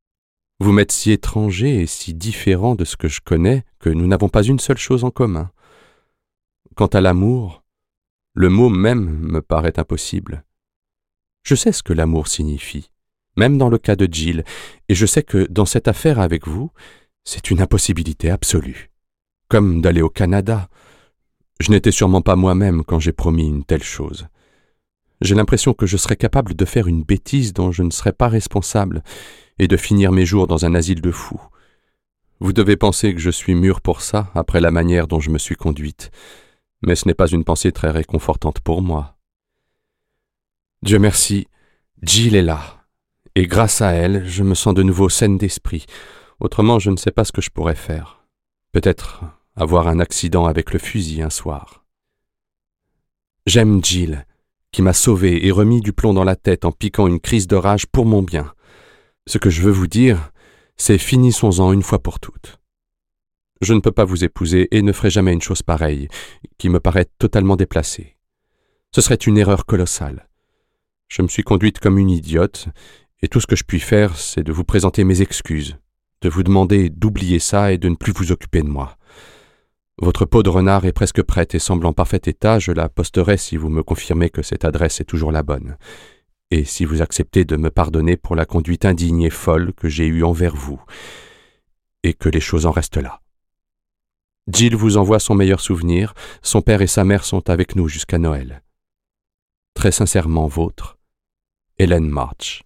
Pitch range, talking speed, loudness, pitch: 85-105 Hz, 185 wpm, -16 LUFS, 95 Hz